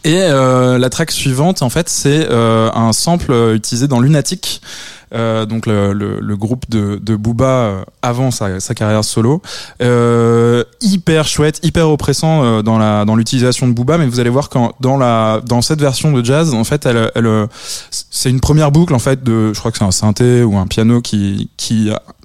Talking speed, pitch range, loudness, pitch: 200 wpm, 110-140 Hz, -13 LUFS, 120 Hz